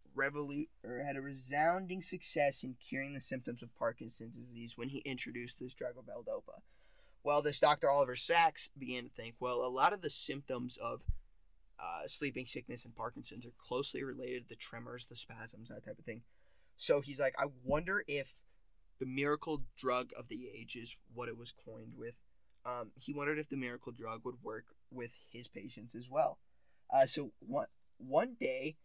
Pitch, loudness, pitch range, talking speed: 125 Hz, -38 LUFS, 120-140 Hz, 180 wpm